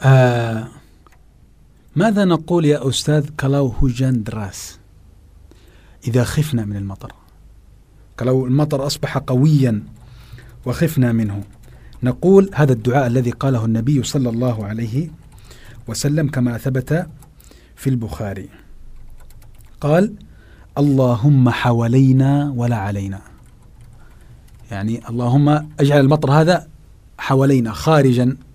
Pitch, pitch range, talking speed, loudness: 125 Hz, 110-140 Hz, 90 wpm, -17 LUFS